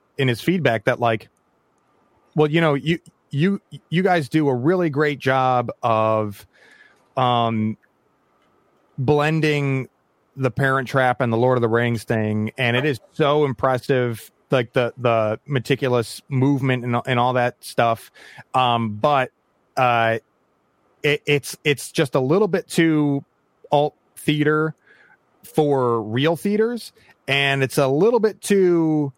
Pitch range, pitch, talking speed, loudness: 120-150 Hz, 135 Hz, 140 wpm, -20 LUFS